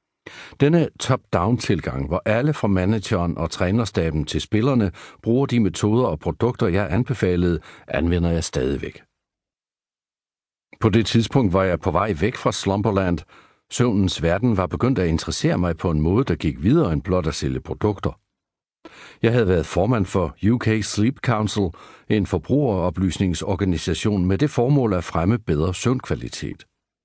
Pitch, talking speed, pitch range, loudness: 100 Hz, 145 wpm, 90-115 Hz, -21 LUFS